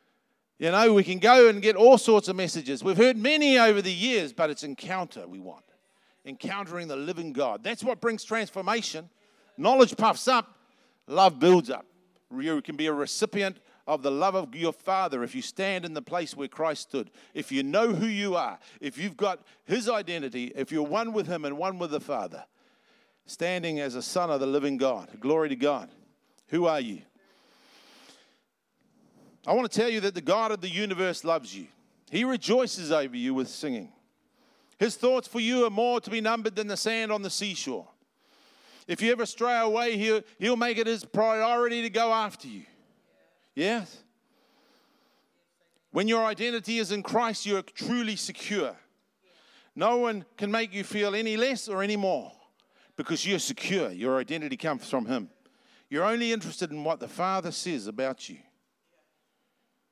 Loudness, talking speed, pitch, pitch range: -27 LUFS, 180 wpm, 215 Hz, 175-240 Hz